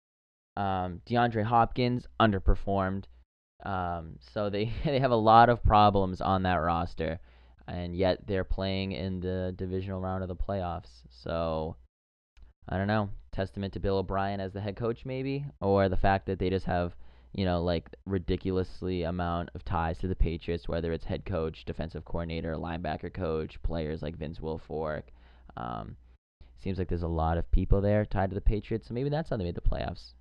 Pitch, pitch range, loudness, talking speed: 90 Hz, 80-100 Hz, -30 LUFS, 180 wpm